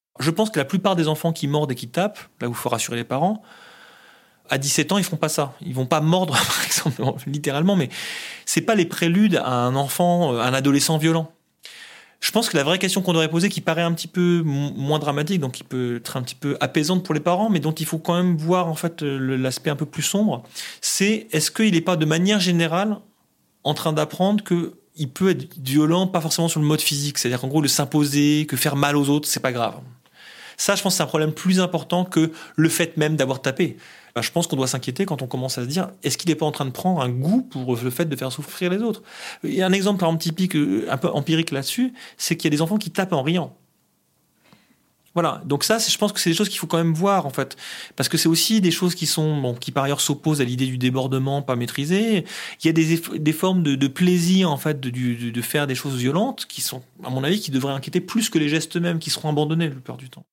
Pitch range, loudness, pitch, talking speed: 140-180 Hz, -21 LUFS, 160 Hz, 260 wpm